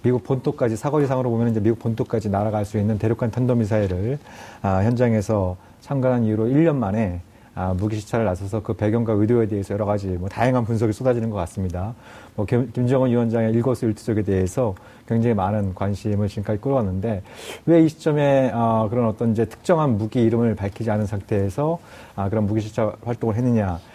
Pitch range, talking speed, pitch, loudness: 105-125 Hz, 405 characters per minute, 115 Hz, -22 LUFS